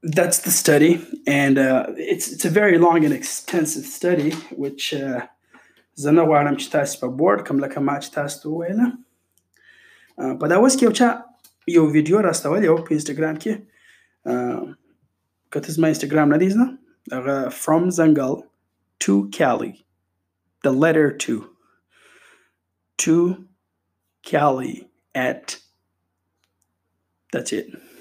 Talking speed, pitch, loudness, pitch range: 80 wpm, 155 Hz, -20 LUFS, 135-180 Hz